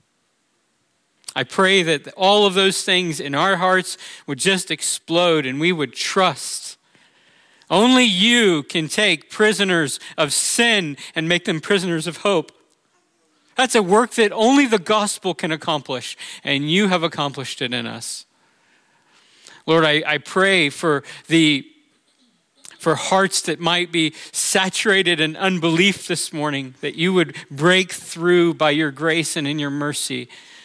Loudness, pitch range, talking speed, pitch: -18 LUFS, 150-195 Hz, 145 wpm, 175 Hz